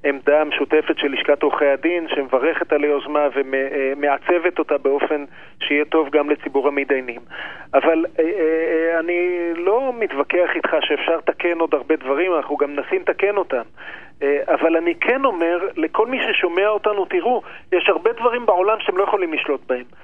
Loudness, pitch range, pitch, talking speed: -19 LUFS, 145-175 Hz, 160 Hz, 150 wpm